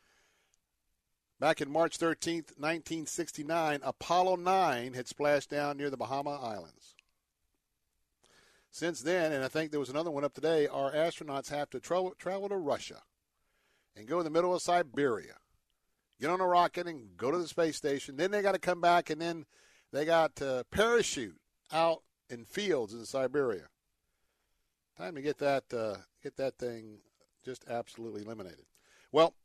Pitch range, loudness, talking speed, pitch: 130-170 Hz, -33 LUFS, 165 wpm, 150 Hz